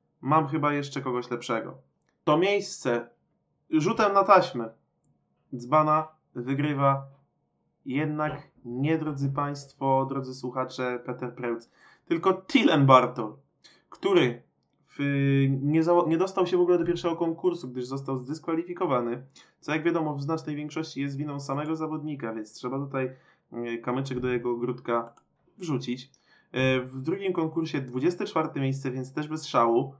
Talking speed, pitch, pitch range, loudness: 130 wpm, 140 Hz, 125-160 Hz, -27 LUFS